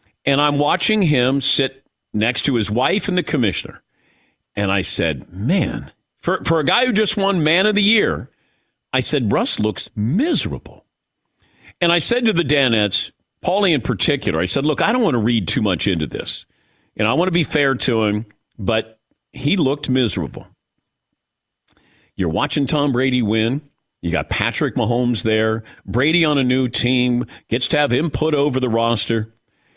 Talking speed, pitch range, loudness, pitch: 175 wpm, 110-150 Hz, -18 LUFS, 125 Hz